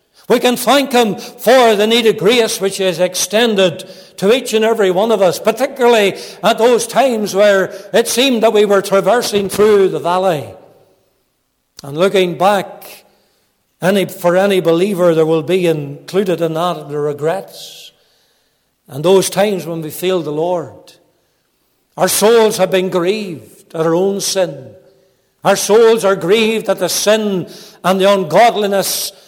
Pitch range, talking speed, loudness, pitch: 175-210 Hz, 155 wpm, -13 LUFS, 195 Hz